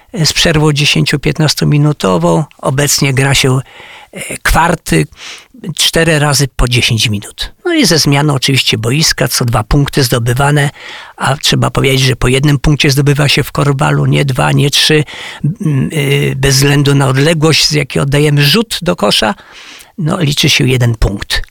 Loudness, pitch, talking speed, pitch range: -10 LUFS, 145 Hz, 150 wpm, 135-150 Hz